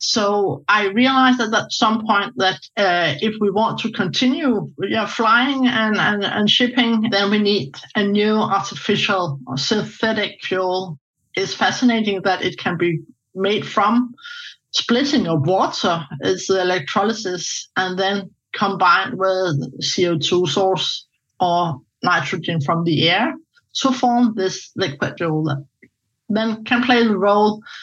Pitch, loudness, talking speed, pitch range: 200 Hz, -18 LUFS, 140 wpm, 180-225 Hz